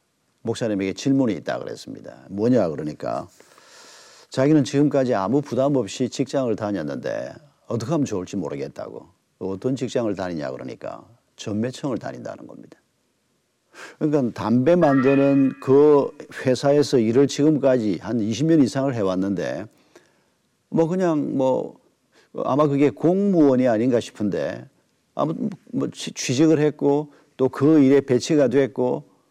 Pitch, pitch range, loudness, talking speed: 135 Hz, 125-145 Hz, -21 LUFS, 290 characters per minute